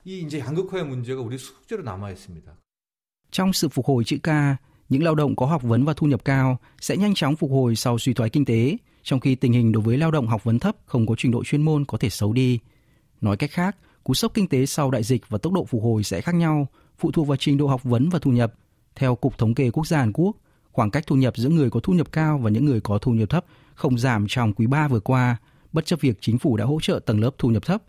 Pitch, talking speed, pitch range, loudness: 135 Hz, 260 wpm, 115-155 Hz, -22 LUFS